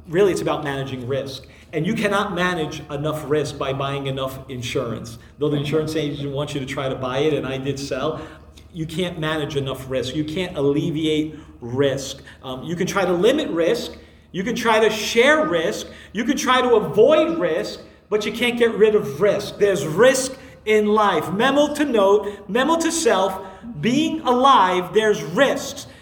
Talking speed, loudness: 180 wpm, -20 LUFS